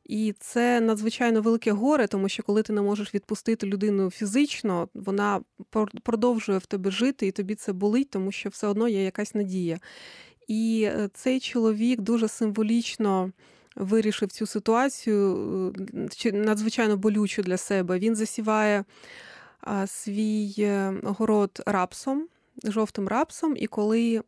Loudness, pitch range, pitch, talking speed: -26 LUFS, 200-230 Hz, 215 Hz, 125 wpm